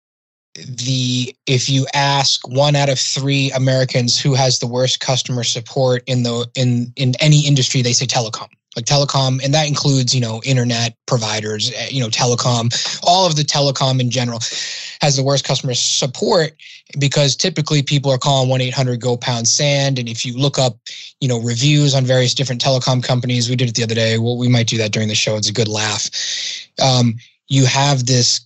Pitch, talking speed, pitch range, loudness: 130 Hz, 195 wpm, 120-140 Hz, -16 LUFS